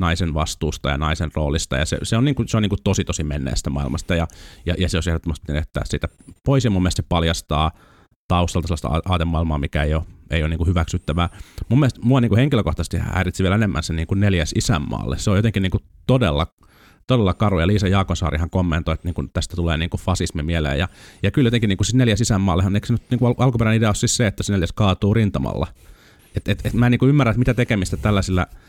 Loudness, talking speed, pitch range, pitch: -20 LUFS, 220 wpm, 80-105 Hz, 90 Hz